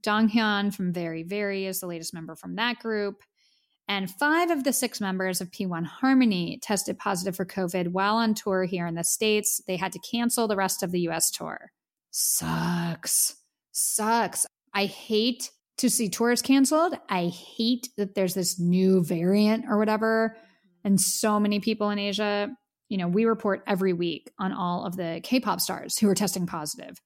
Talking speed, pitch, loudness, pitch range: 175 wpm, 200 Hz, -26 LUFS, 185-225 Hz